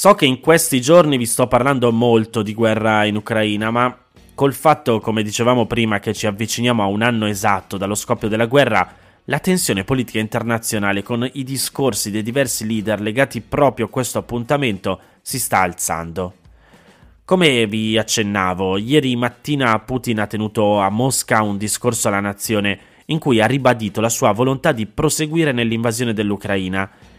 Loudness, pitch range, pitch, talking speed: -17 LUFS, 105-130 Hz, 115 Hz, 160 wpm